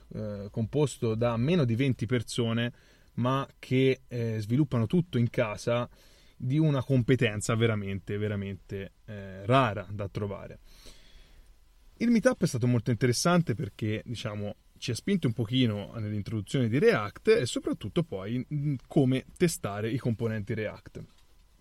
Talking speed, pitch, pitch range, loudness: 120 wpm, 120 Hz, 105-135 Hz, -29 LUFS